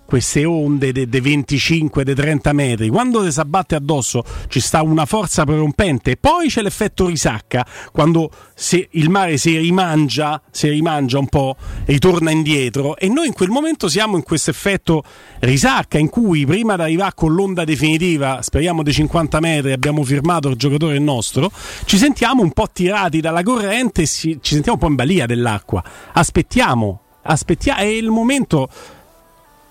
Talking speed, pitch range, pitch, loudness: 160 wpm, 145-185 Hz, 160 Hz, -16 LUFS